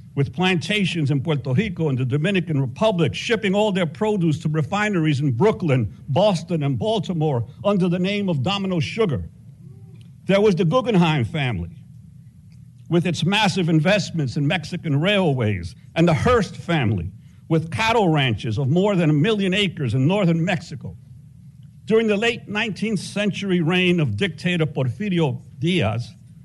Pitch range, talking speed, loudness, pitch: 140-190 Hz, 145 wpm, -21 LUFS, 160 Hz